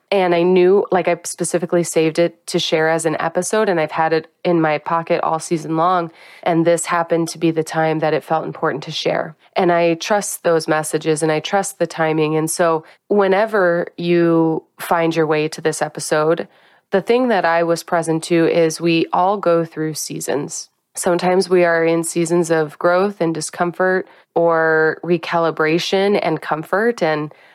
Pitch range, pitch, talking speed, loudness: 160-175 Hz, 170 Hz, 180 wpm, -17 LUFS